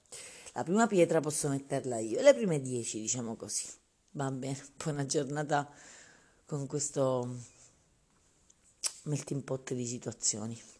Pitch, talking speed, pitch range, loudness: 140 Hz, 120 wpm, 125-150 Hz, -33 LUFS